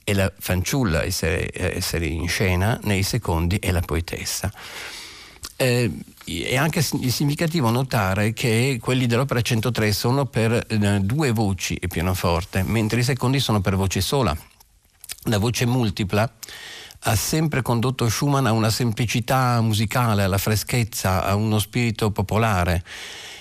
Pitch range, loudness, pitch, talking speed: 95-125 Hz, -22 LUFS, 110 Hz, 125 wpm